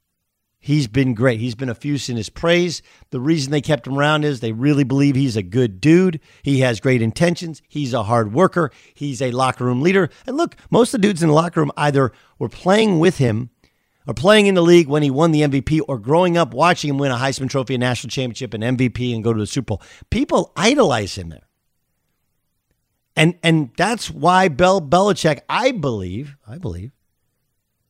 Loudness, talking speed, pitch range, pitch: -18 LUFS, 205 wpm, 125-165 Hz, 140 Hz